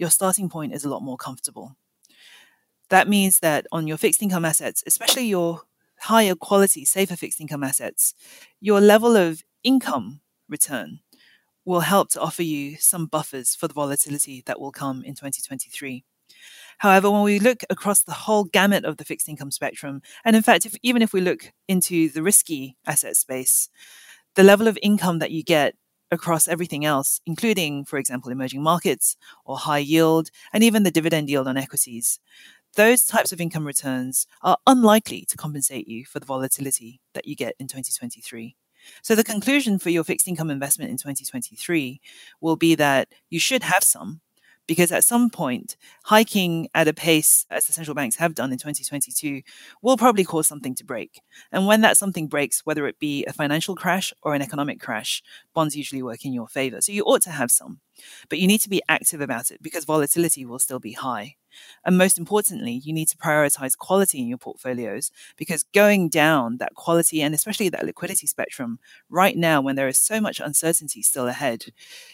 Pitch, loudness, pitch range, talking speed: 165 Hz, -21 LUFS, 140-200 Hz, 185 wpm